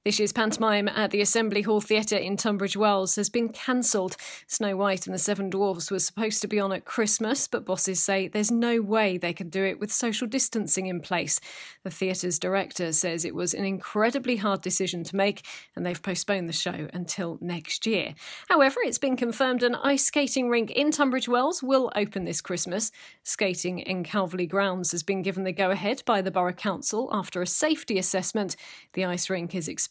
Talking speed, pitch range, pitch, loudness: 200 wpm, 185-225 Hz, 200 Hz, -26 LUFS